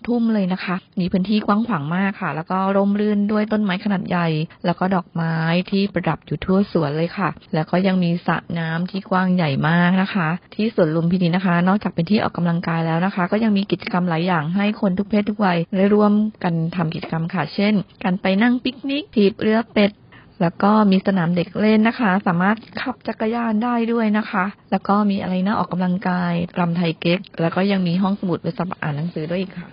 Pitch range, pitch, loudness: 175-205 Hz, 185 Hz, -20 LUFS